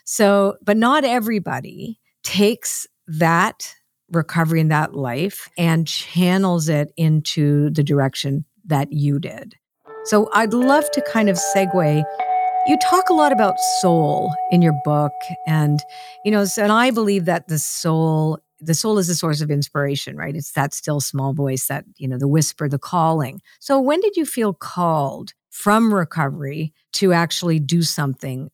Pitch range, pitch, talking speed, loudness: 150-210 Hz, 170 Hz, 160 wpm, -19 LUFS